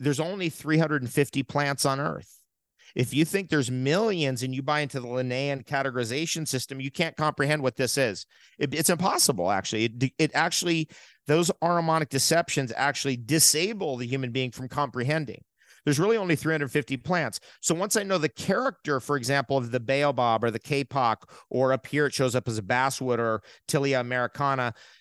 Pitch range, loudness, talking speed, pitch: 130-155 Hz, -26 LUFS, 175 wpm, 140 Hz